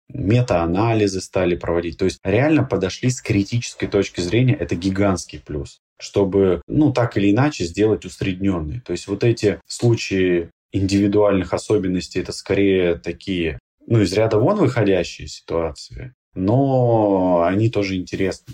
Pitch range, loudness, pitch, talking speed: 90-115 Hz, -19 LUFS, 100 Hz, 135 wpm